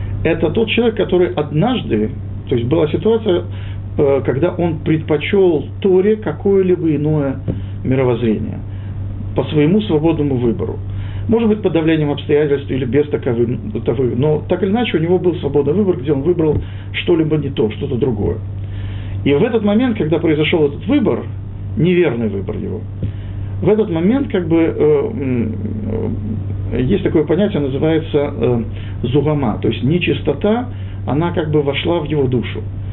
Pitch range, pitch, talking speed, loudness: 105-165 Hz, 135 Hz, 140 wpm, -17 LUFS